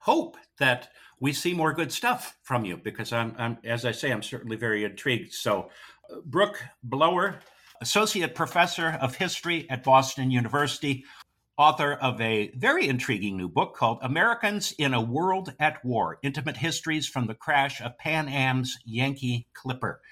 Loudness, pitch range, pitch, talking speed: -26 LUFS, 120-160 Hz, 135 Hz, 160 wpm